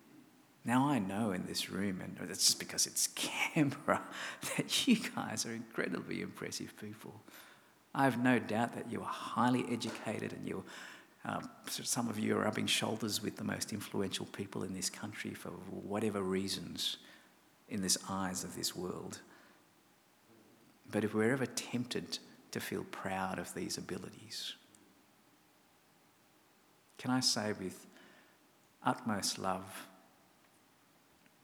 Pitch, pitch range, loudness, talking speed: 110 Hz, 95-125 Hz, -36 LUFS, 135 wpm